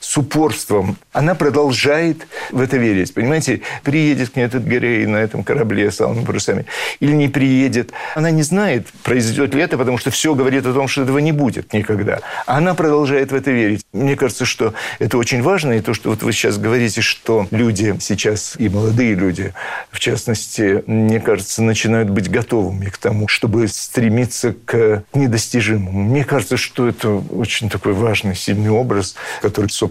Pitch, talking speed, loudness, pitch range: 120 Hz, 175 wpm, -16 LUFS, 110-135 Hz